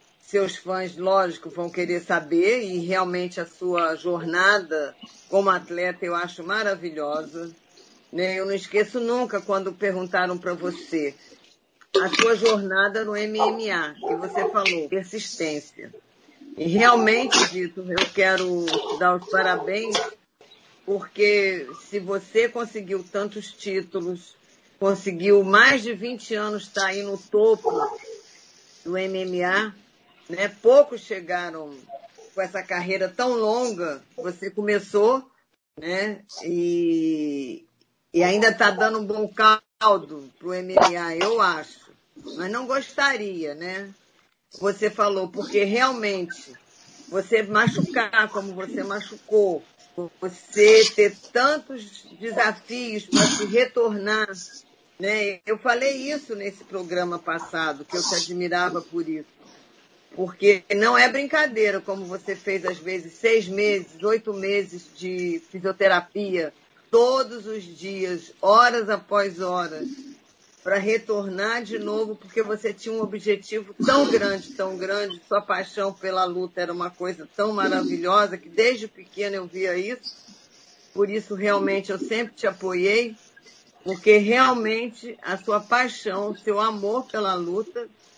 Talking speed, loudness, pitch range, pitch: 125 wpm, -23 LUFS, 180-220 Hz, 200 Hz